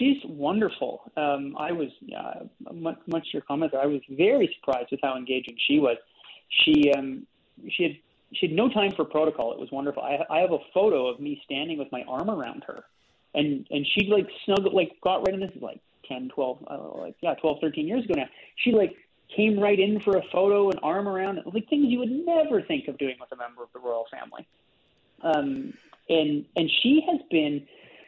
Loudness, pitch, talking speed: -26 LUFS, 190 Hz, 215 wpm